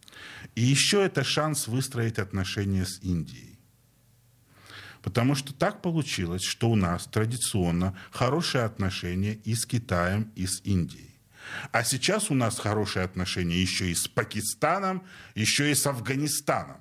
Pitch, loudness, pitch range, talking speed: 115 Hz, -27 LUFS, 95-135 Hz, 135 wpm